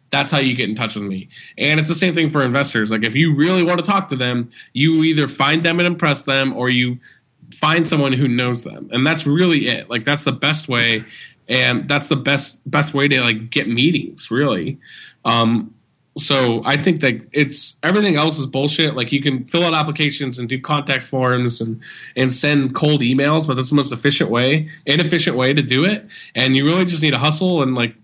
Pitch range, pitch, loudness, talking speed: 125-155 Hz, 140 Hz, -17 LUFS, 220 wpm